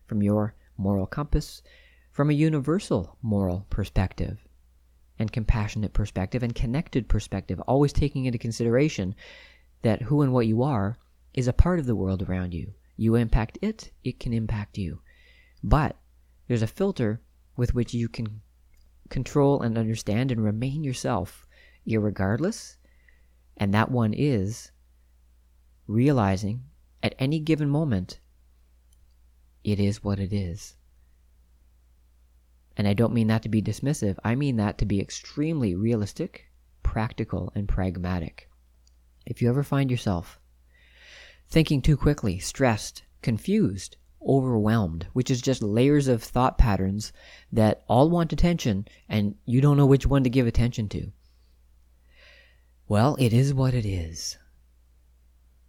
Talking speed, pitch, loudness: 135 wpm, 105 Hz, -26 LUFS